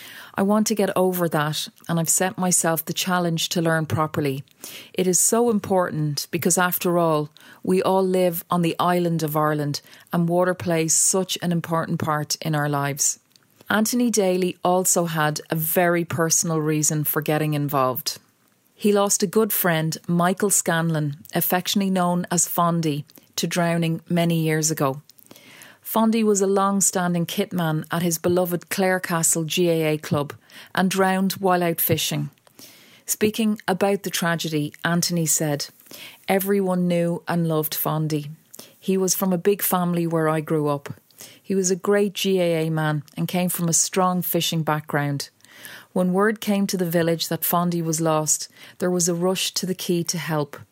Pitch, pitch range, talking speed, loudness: 170 Hz, 155-185 Hz, 165 wpm, -22 LUFS